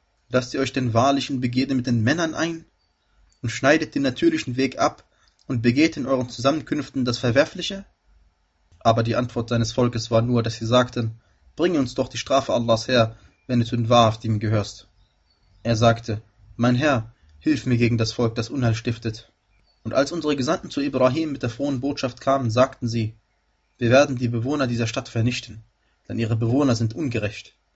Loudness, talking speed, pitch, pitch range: -22 LUFS, 180 wpm, 120 Hz, 110-135 Hz